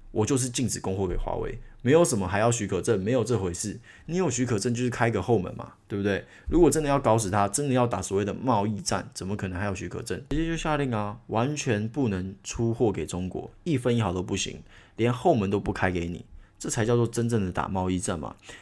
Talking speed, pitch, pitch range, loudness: 350 characters per minute, 110 Hz, 95-125 Hz, -27 LUFS